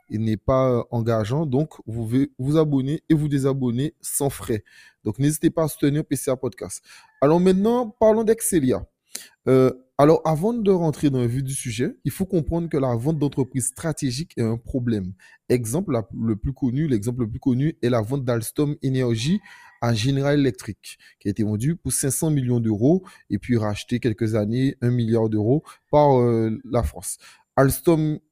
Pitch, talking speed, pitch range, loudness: 135 Hz, 175 wpm, 120-150 Hz, -22 LUFS